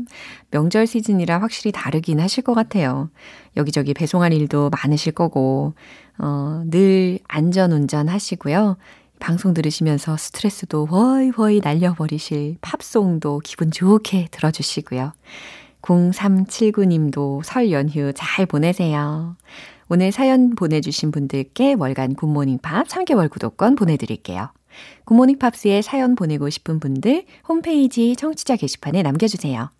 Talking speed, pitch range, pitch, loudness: 290 characters per minute, 150-220 Hz, 175 Hz, -19 LUFS